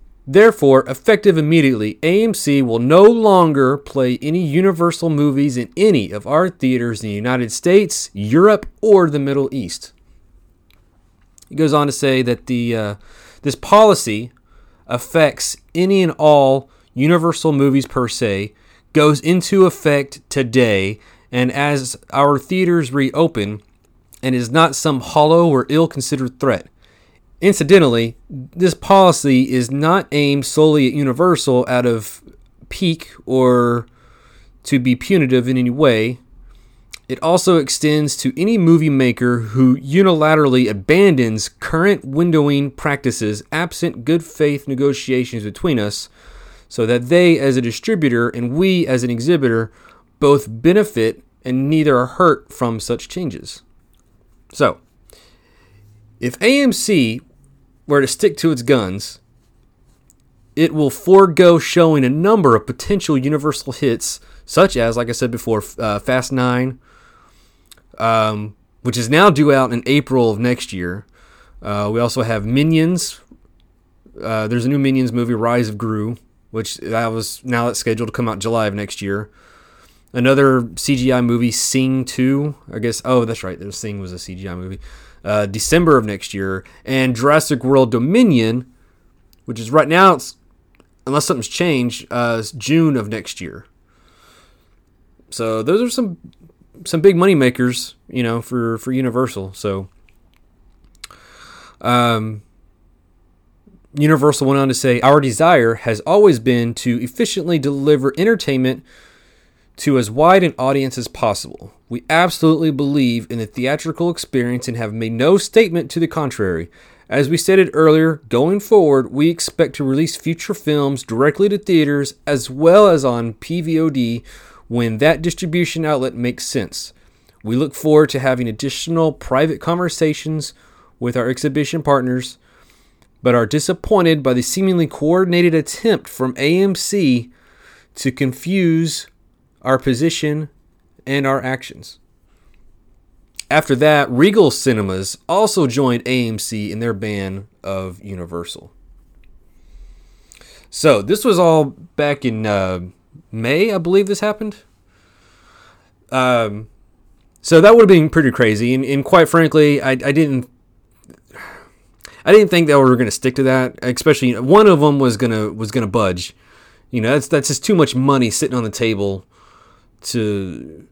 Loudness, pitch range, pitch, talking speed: -15 LUFS, 110-155 Hz, 130 Hz, 140 wpm